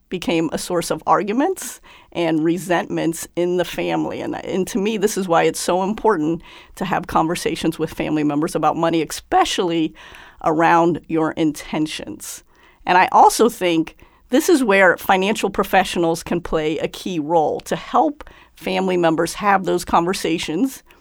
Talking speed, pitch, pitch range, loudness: 150 wpm, 175 Hz, 165-205 Hz, -19 LUFS